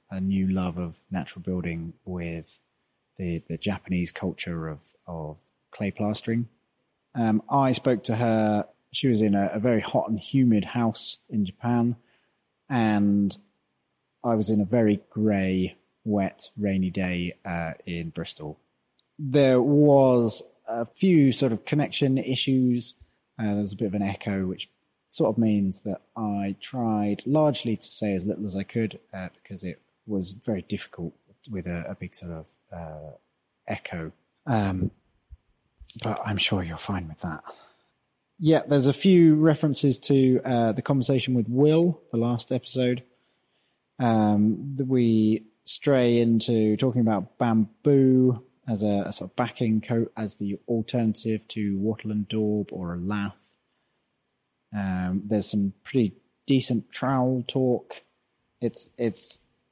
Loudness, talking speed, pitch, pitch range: -25 LUFS, 145 wpm, 110 Hz, 95-125 Hz